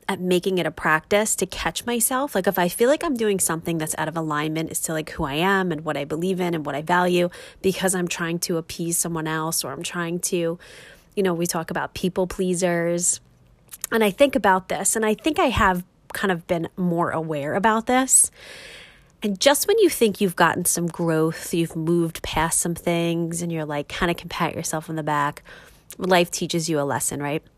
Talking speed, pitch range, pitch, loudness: 220 wpm, 160-190 Hz, 175 Hz, -22 LUFS